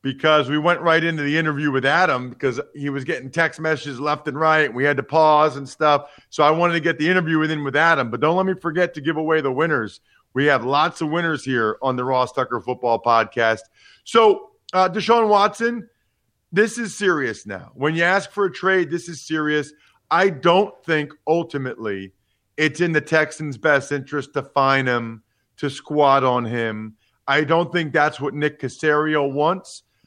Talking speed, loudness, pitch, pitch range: 200 wpm, -20 LUFS, 150 Hz, 135-165 Hz